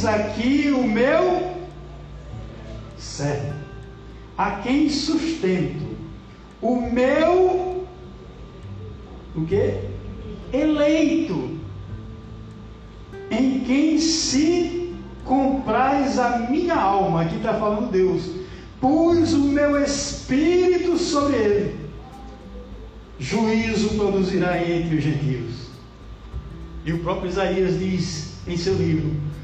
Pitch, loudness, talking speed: 195 Hz, -21 LUFS, 85 wpm